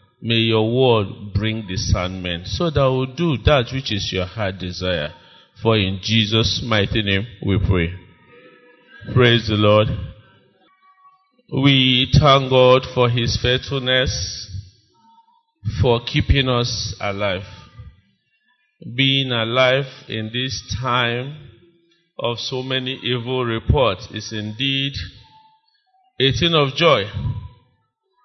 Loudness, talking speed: -19 LUFS, 110 wpm